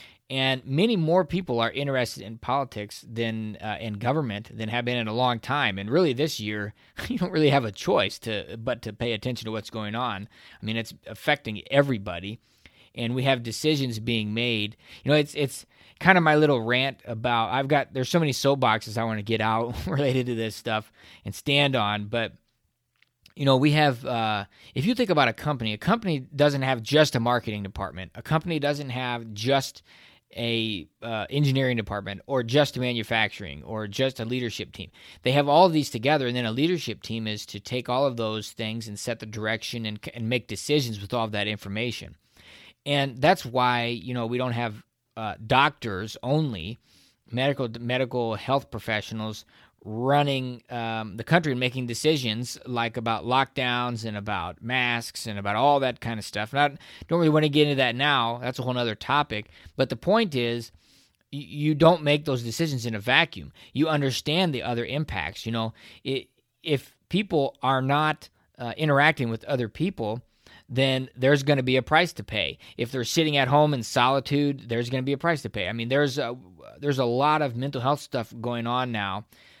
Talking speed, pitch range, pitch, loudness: 195 wpm, 110-140 Hz, 125 Hz, -25 LUFS